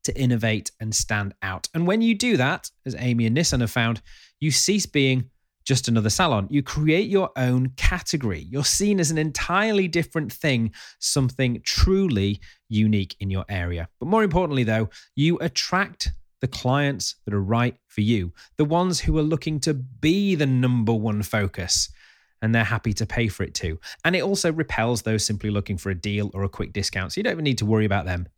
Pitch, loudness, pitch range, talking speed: 120 Hz, -23 LUFS, 105-150 Hz, 200 wpm